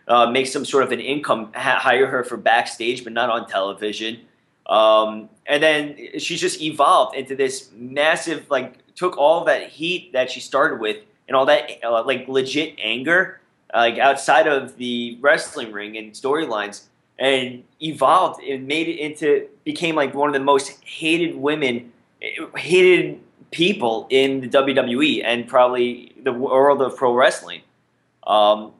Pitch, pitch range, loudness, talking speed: 135 Hz, 120-150 Hz, -19 LUFS, 160 wpm